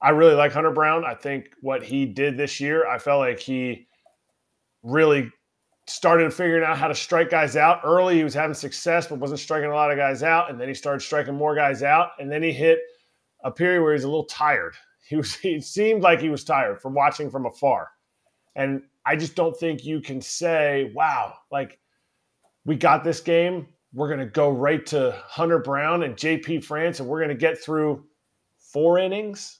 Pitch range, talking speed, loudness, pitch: 140-165 Hz, 205 wpm, -22 LUFS, 150 Hz